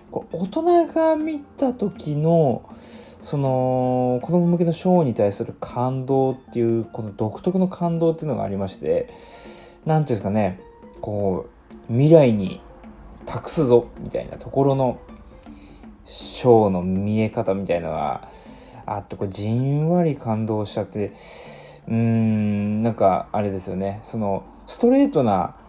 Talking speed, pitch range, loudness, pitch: 280 characters per minute, 105-160 Hz, -22 LUFS, 120 Hz